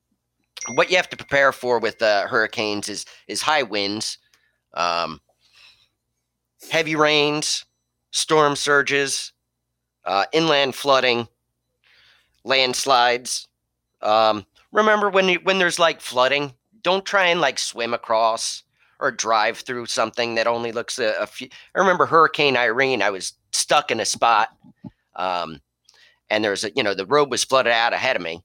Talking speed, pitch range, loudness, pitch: 145 wpm, 105-150 Hz, -20 LUFS, 120 Hz